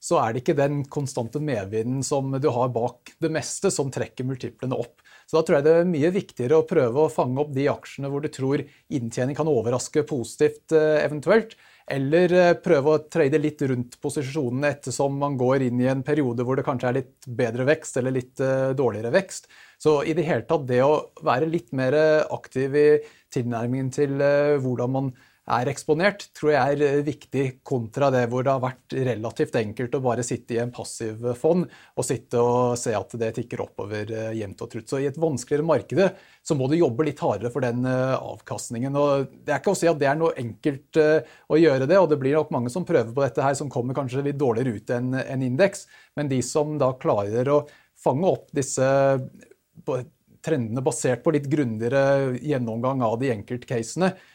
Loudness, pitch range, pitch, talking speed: -24 LUFS, 125-150 Hz, 135 Hz, 195 wpm